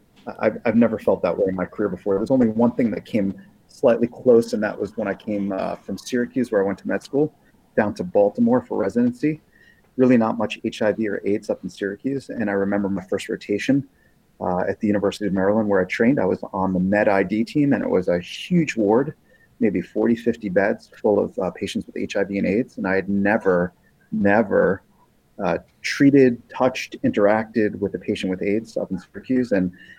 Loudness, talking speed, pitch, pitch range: -22 LUFS, 210 wpm, 105 Hz, 95-125 Hz